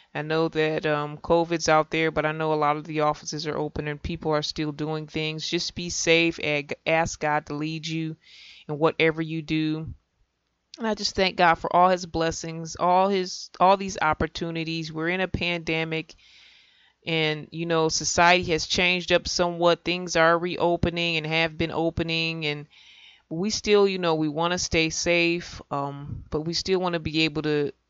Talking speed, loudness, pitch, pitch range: 190 wpm, -24 LUFS, 160 Hz, 155-170 Hz